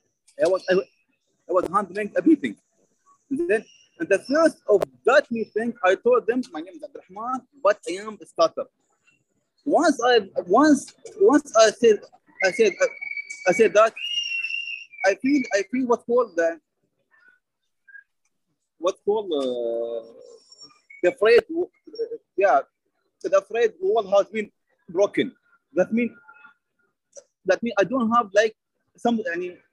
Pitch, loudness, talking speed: 270 Hz, -22 LUFS, 145 wpm